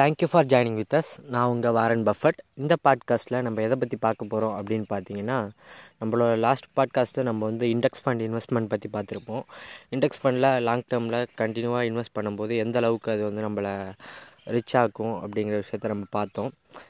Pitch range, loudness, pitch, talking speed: 110-125 Hz, -26 LUFS, 115 Hz, 165 wpm